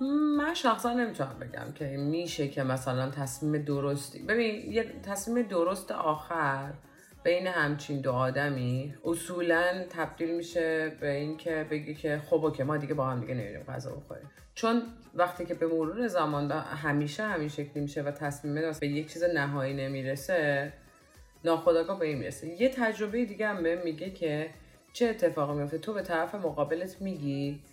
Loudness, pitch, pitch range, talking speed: -31 LUFS, 155 Hz, 145-175 Hz, 155 wpm